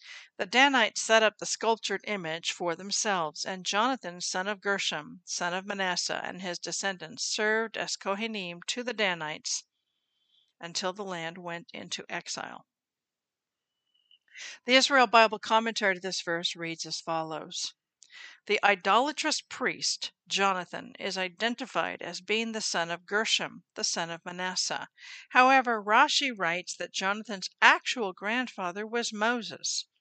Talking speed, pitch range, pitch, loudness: 135 wpm, 175-225 Hz, 195 Hz, -28 LUFS